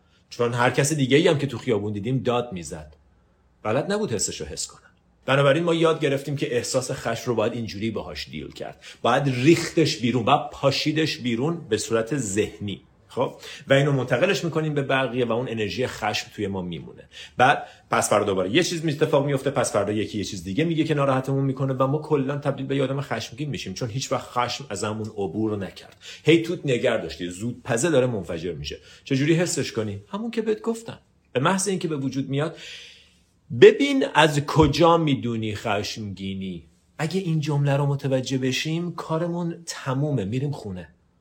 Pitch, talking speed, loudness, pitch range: 135 Hz, 185 wpm, -23 LUFS, 110-155 Hz